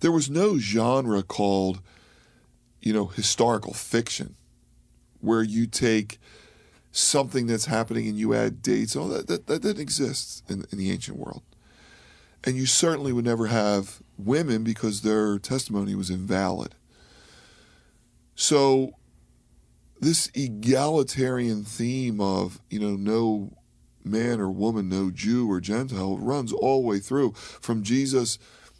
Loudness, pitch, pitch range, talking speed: -25 LUFS, 110 Hz, 100-130 Hz, 135 wpm